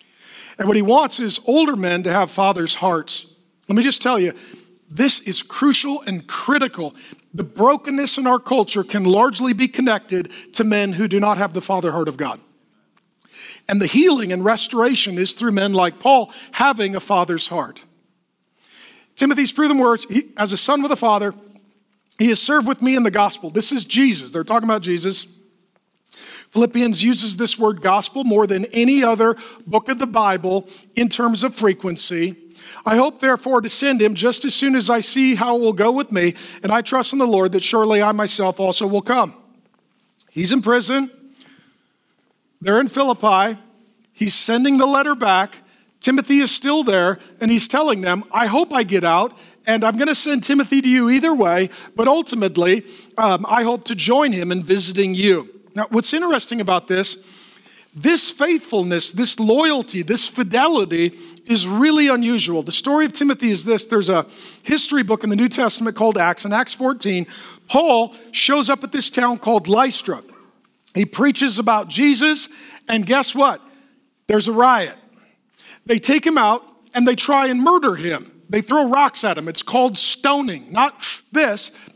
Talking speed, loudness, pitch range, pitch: 180 wpm, -17 LUFS, 195-265 Hz, 230 Hz